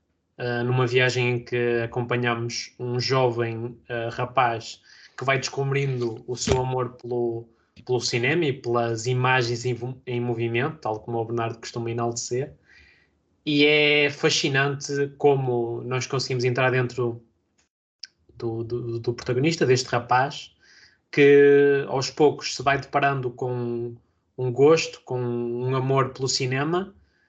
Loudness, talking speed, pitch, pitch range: -23 LUFS, 130 wpm, 125 Hz, 120-135 Hz